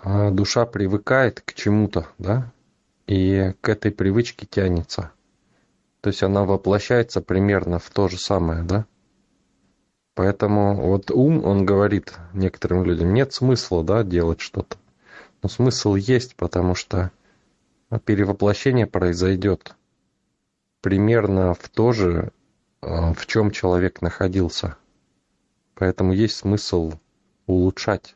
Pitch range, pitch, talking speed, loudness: 90-105 Hz, 100 Hz, 110 wpm, -21 LUFS